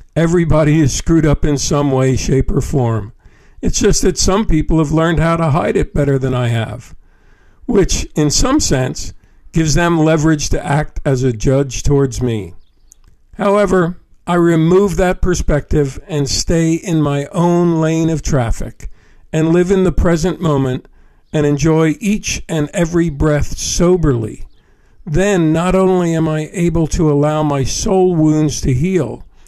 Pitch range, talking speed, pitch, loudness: 140-175 Hz, 160 wpm, 155 Hz, -15 LUFS